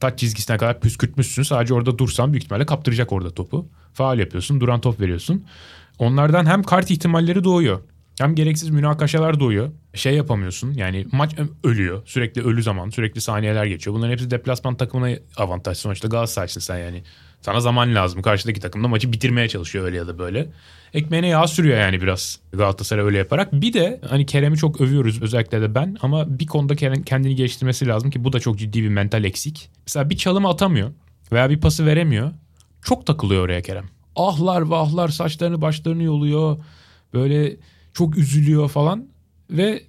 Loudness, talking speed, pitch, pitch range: -20 LUFS, 170 wpm, 125 Hz, 105-150 Hz